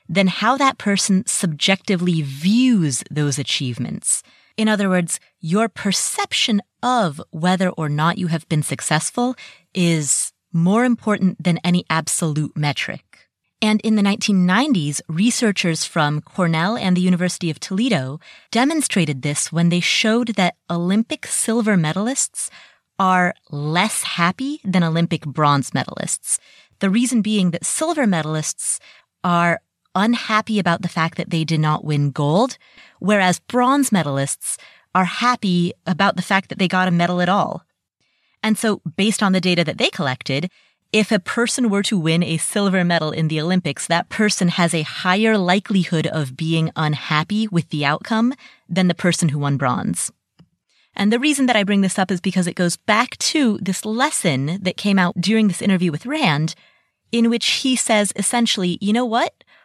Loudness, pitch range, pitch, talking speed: -19 LUFS, 165-215 Hz, 185 Hz, 160 wpm